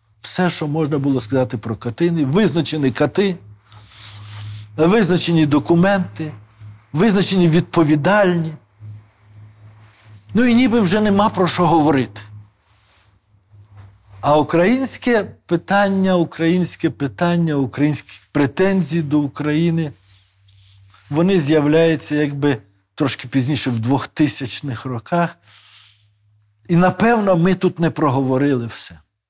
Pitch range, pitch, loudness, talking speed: 105-170 Hz, 145 Hz, -17 LUFS, 95 wpm